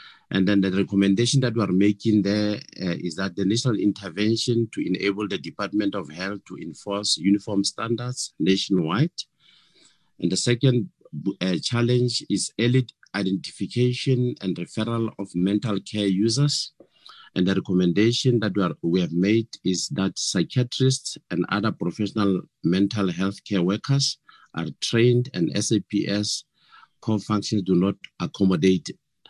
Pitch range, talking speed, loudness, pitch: 95-120 Hz, 140 wpm, -24 LUFS, 105 Hz